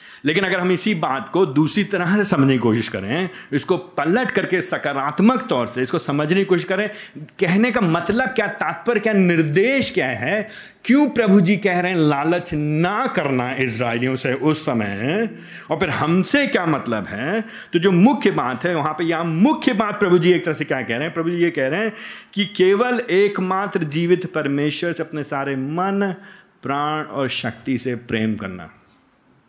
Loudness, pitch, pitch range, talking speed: -19 LUFS, 175 Hz, 145-200 Hz, 185 wpm